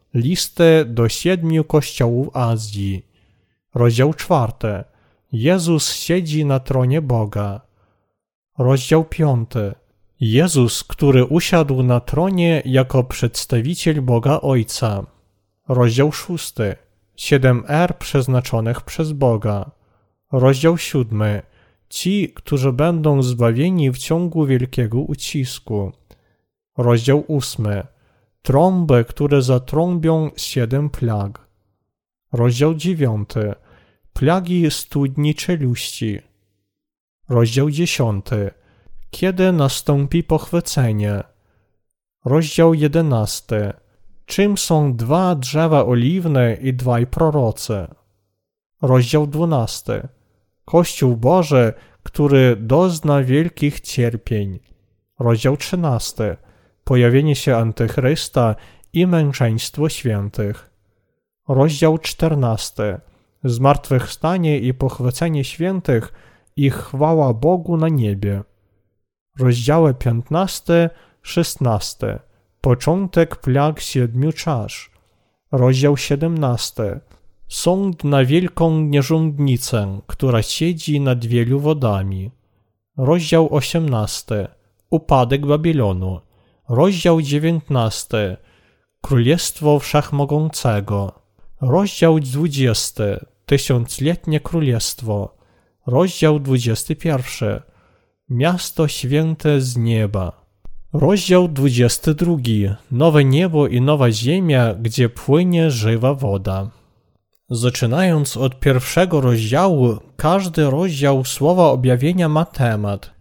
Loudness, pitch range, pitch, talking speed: -17 LUFS, 115-155 Hz, 130 Hz, 80 wpm